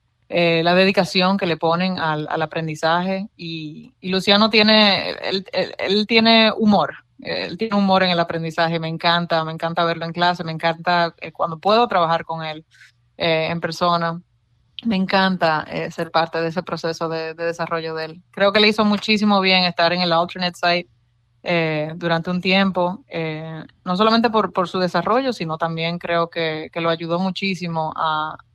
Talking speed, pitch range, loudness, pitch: 180 wpm, 165-190 Hz, -19 LUFS, 170 Hz